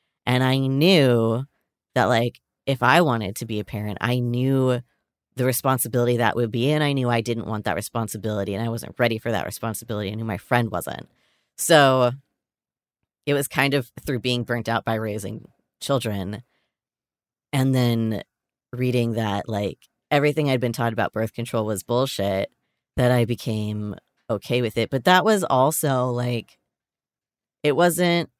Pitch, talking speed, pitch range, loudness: 120 Hz, 165 wpm, 110-130 Hz, -22 LUFS